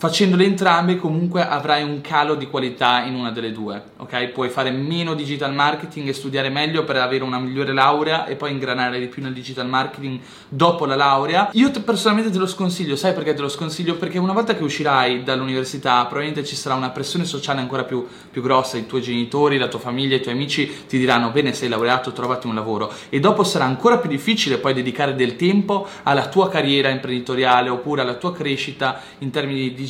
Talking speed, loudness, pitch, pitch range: 205 wpm, -20 LUFS, 135 Hz, 130-155 Hz